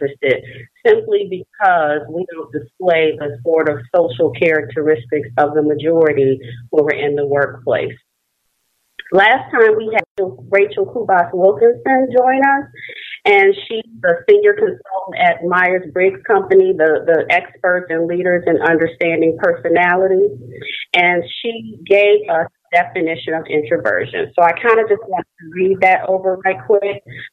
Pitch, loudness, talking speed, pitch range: 180 Hz, -15 LUFS, 140 wpm, 160-225 Hz